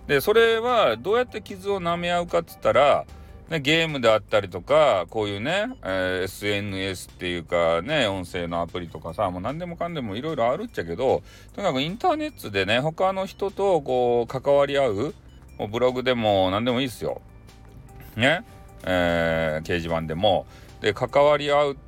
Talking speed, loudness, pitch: 360 characters per minute, -23 LUFS, 120 Hz